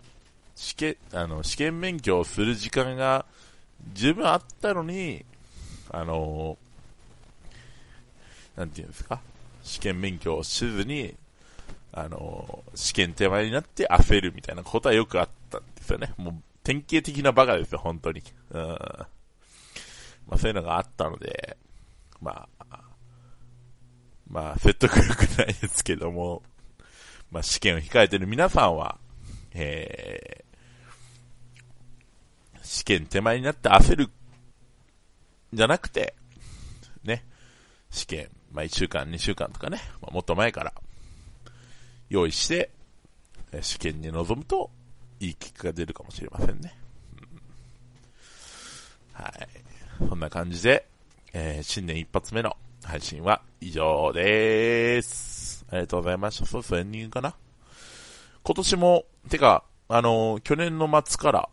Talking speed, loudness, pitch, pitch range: 245 characters per minute, -26 LUFS, 110 Hz, 85-125 Hz